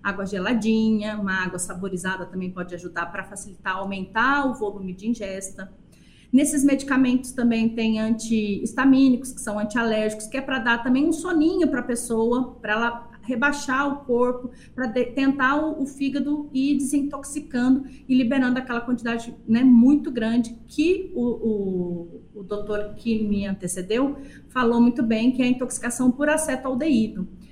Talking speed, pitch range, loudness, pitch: 155 wpm, 210-265 Hz, -23 LUFS, 240 Hz